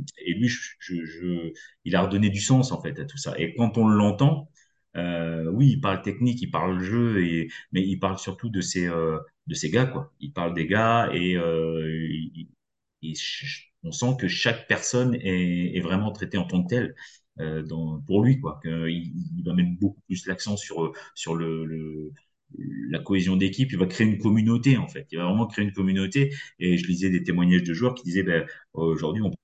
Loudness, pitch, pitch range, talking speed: -25 LUFS, 95 Hz, 85-115 Hz, 210 wpm